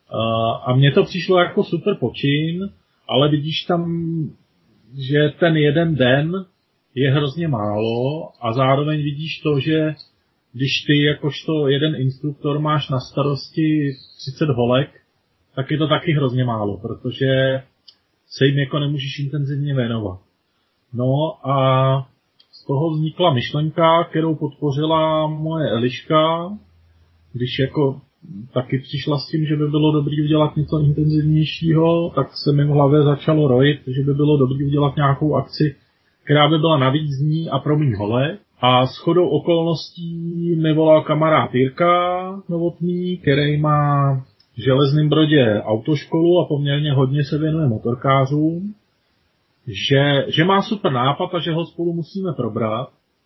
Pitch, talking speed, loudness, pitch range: 145 Hz, 140 wpm, -19 LUFS, 135-160 Hz